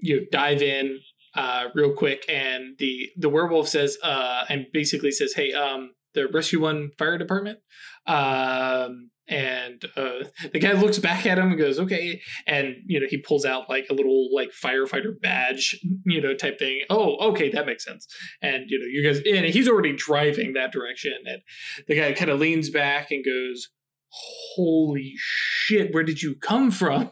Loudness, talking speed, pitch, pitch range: -23 LUFS, 180 wpm, 150 Hz, 135-180 Hz